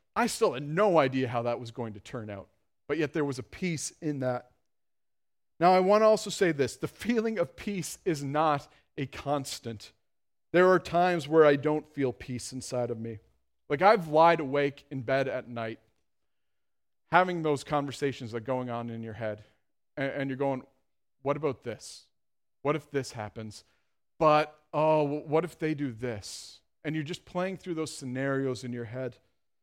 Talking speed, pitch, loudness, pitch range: 185 wpm, 140 Hz, -29 LUFS, 120-155 Hz